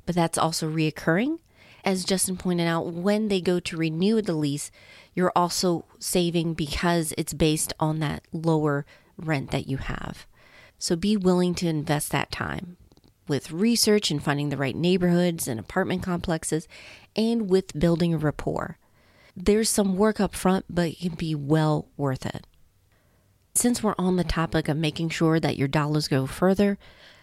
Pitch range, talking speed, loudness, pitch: 150-185 Hz, 165 wpm, -25 LUFS, 165 Hz